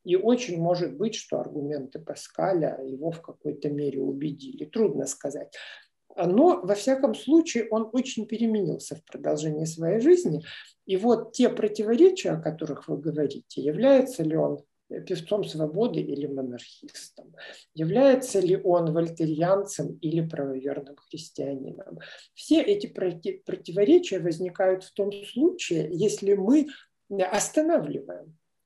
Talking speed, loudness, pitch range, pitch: 120 wpm, -26 LUFS, 155-230 Hz, 185 Hz